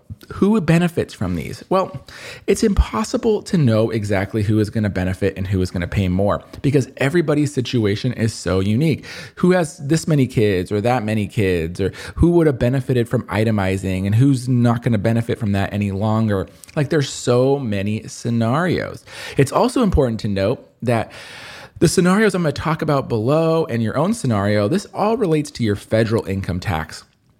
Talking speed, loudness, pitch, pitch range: 185 wpm, -19 LUFS, 115 Hz, 100-150 Hz